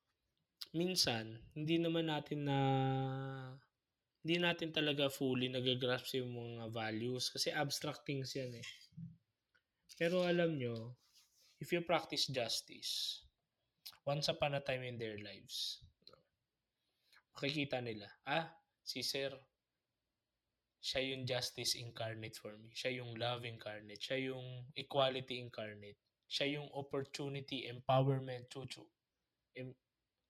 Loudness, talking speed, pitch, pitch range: -40 LUFS, 115 wpm, 130 Hz, 120-140 Hz